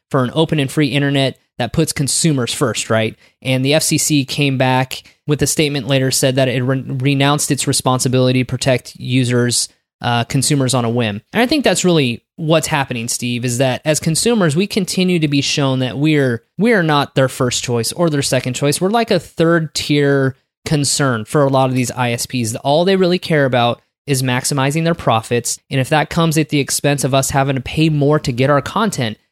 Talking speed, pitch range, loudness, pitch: 205 wpm, 125-155 Hz, -16 LUFS, 140 Hz